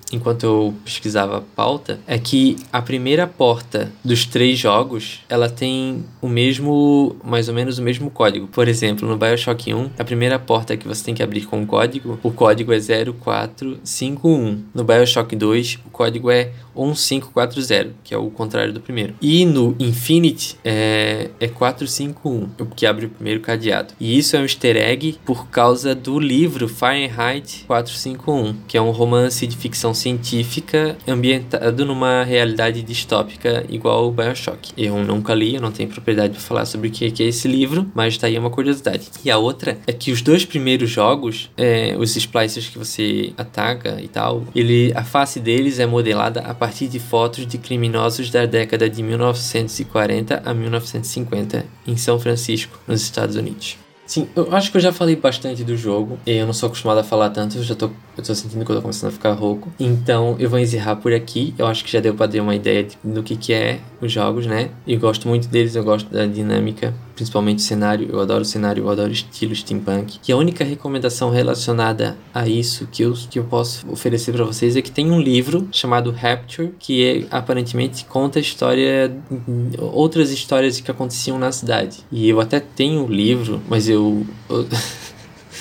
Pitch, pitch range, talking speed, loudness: 120 Hz, 110-130 Hz, 190 wpm, -18 LUFS